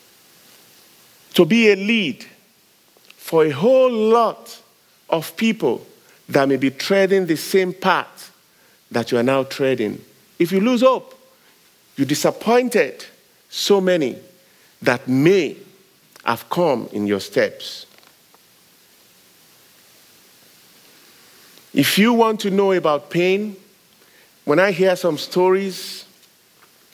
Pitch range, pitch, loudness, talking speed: 150-220 Hz, 190 Hz, -18 LUFS, 110 wpm